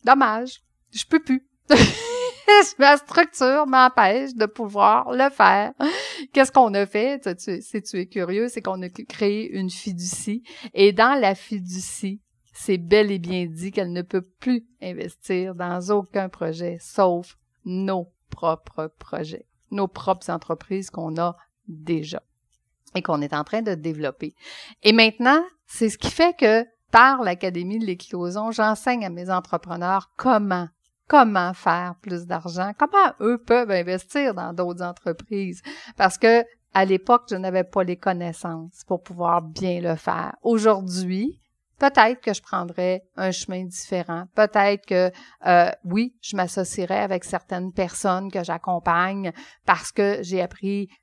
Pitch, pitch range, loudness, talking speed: 190 Hz, 180-225 Hz, -21 LUFS, 145 wpm